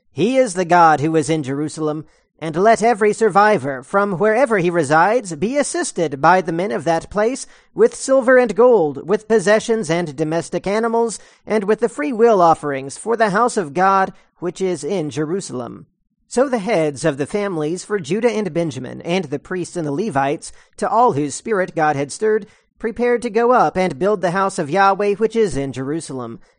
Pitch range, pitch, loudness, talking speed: 160-220 Hz, 190 Hz, -17 LUFS, 190 wpm